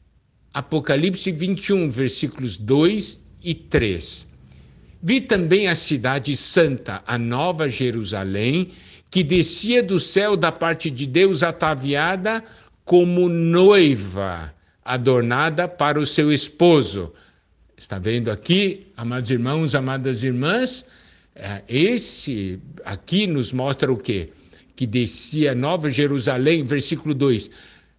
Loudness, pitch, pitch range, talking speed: -20 LUFS, 140 Hz, 115-175 Hz, 105 wpm